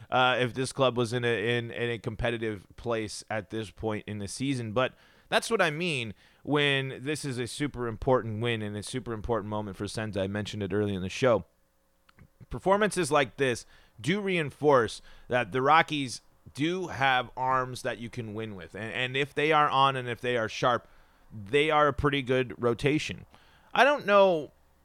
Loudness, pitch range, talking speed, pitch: -28 LUFS, 110-140 Hz, 195 wpm, 125 Hz